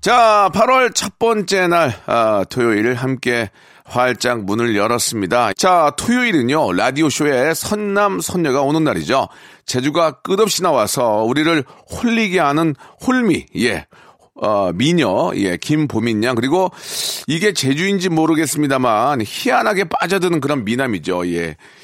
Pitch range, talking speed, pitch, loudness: 125-195 Hz, 280 characters per minute, 160 Hz, -16 LUFS